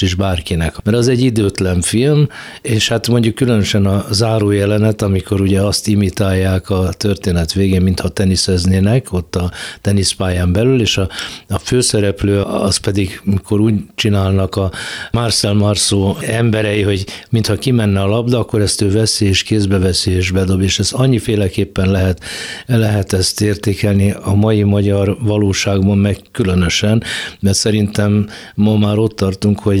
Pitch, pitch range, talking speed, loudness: 100 Hz, 95-110 Hz, 150 wpm, -14 LUFS